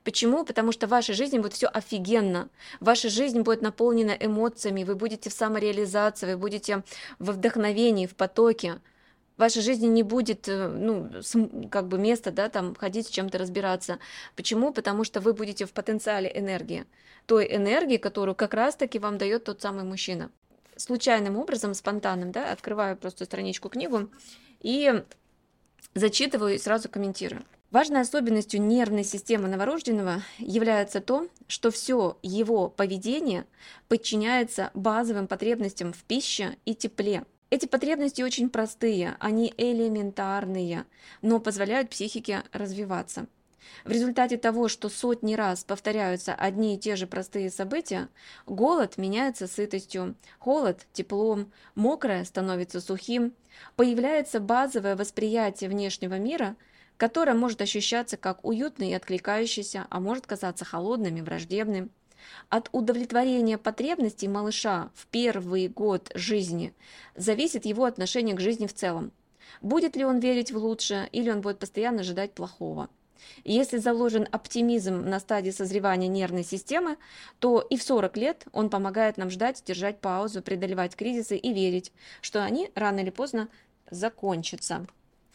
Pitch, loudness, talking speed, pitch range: 215 Hz, -28 LUFS, 135 wpm, 195-235 Hz